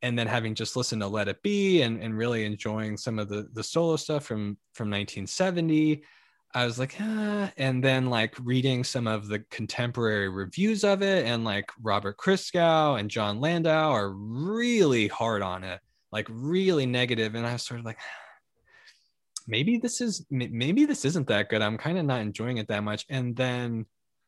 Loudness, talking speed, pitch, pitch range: -27 LUFS, 190 wpm, 120 Hz, 110-155 Hz